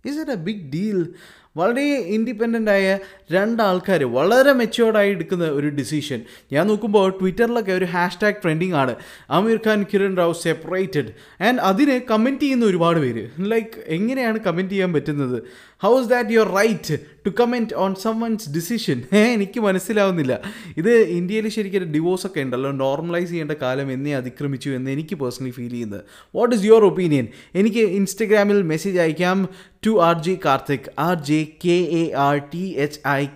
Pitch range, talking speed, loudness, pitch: 150-215 Hz, 150 wpm, -20 LUFS, 185 Hz